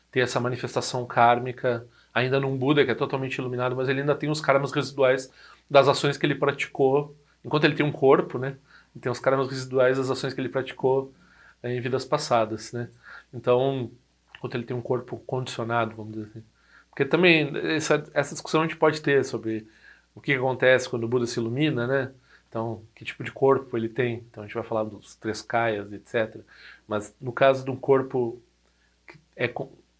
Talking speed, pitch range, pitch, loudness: 190 wpm, 120-140 Hz, 130 Hz, -25 LUFS